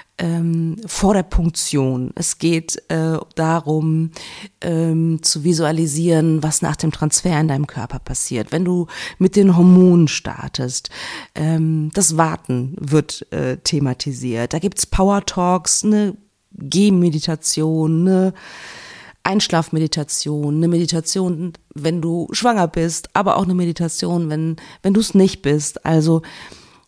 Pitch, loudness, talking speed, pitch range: 165 Hz, -18 LUFS, 125 wpm, 155-180 Hz